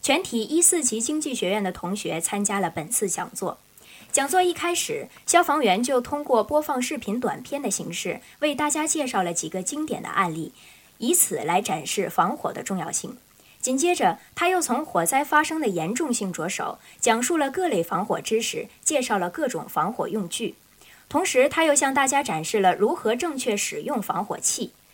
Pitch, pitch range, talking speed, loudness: 270 Hz, 205-305 Hz, 280 characters per minute, -24 LUFS